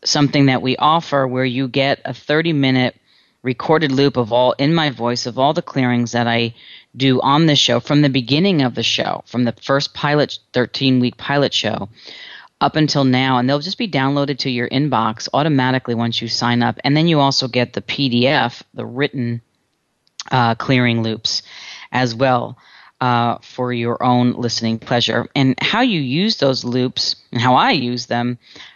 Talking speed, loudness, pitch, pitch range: 185 wpm, -17 LUFS, 130 Hz, 120-140 Hz